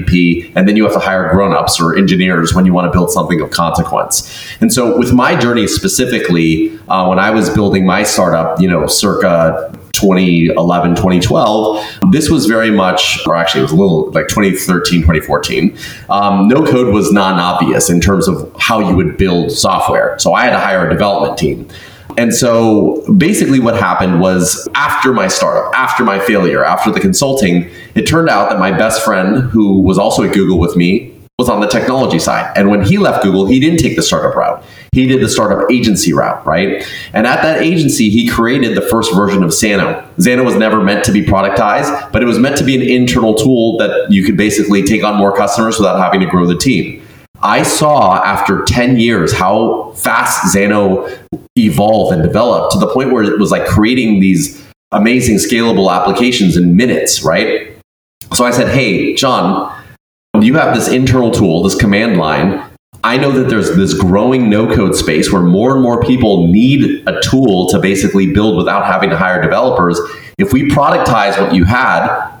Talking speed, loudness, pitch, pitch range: 190 wpm, -11 LUFS, 100 Hz, 90-120 Hz